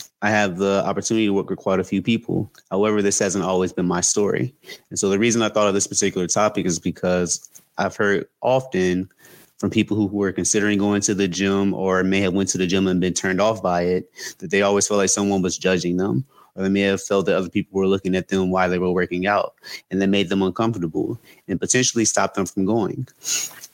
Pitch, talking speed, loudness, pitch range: 95 Hz, 235 wpm, -21 LUFS, 95-100 Hz